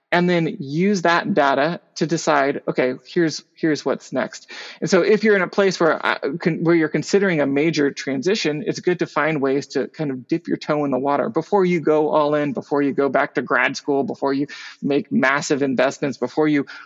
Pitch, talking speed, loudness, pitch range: 155 Hz, 215 wpm, -20 LUFS, 140-170 Hz